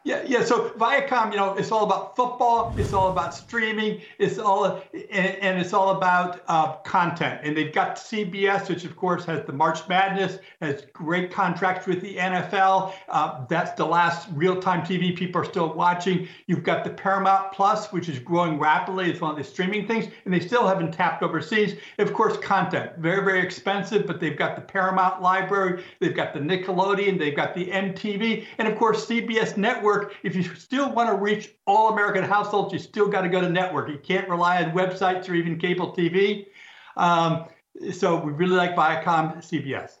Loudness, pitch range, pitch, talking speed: -24 LUFS, 175-205 Hz, 185 Hz, 195 wpm